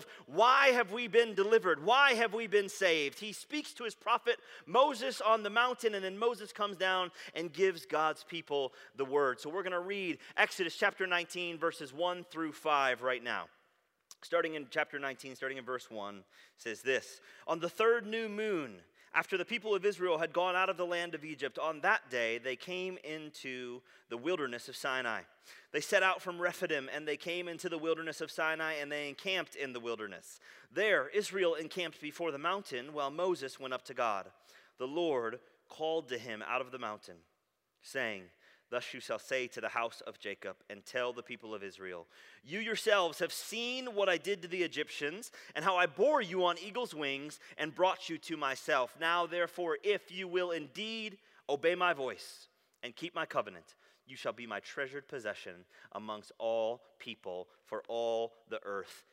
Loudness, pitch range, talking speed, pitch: -34 LUFS, 145-200 Hz, 190 wpm, 170 Hz